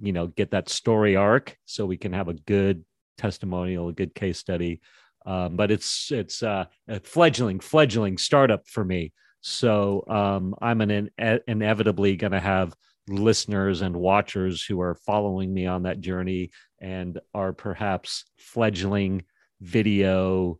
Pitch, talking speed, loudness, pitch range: 95 Hz, 150 wpm, -25 LUFS, 90-105 Hz